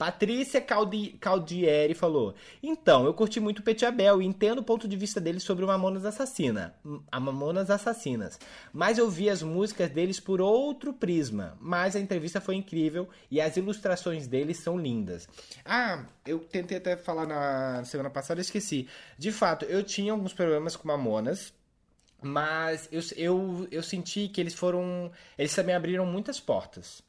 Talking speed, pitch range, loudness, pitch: 165 wpm, 160-205 Hz, -29 LUFS, 180 Hz